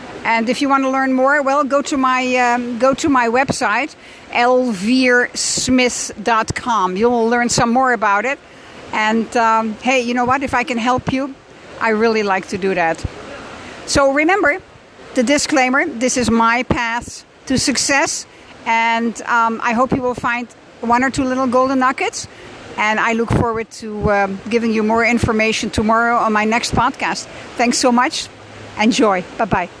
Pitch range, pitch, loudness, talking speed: 230-260 Hz, 245 Hz, -16 LUFS, 165 wpm